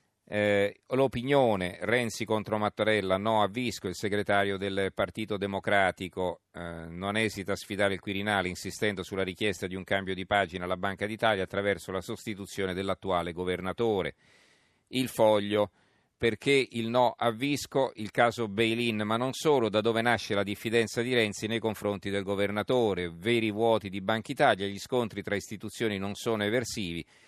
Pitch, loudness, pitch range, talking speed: 105 Hz, -29 LUFS, 100-115 Hz, 160 wpm